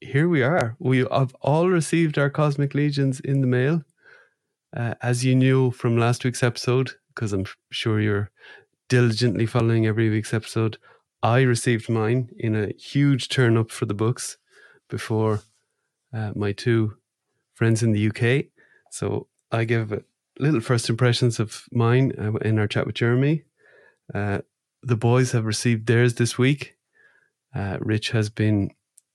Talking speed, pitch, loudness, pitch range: 155 wpm, 120 Hz, -23 LUFS, 110-130 Hz